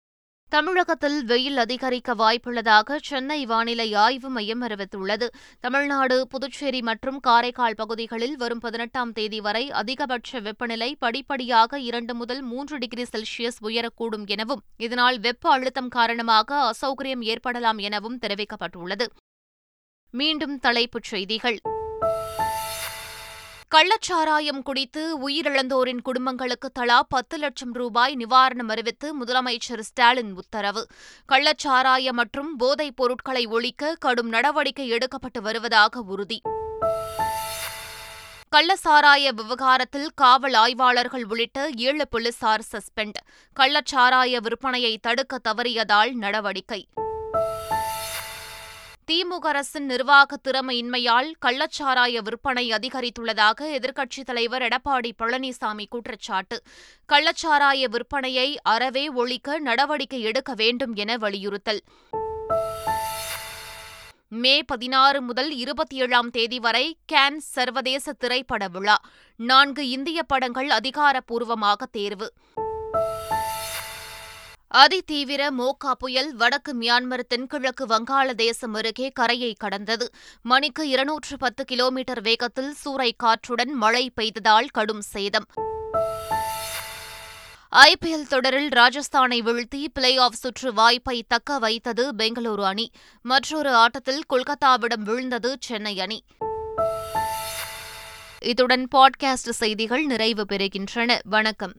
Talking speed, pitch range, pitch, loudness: 95 wpm, 225-275 Hz, 245 Hz, -22 LUFS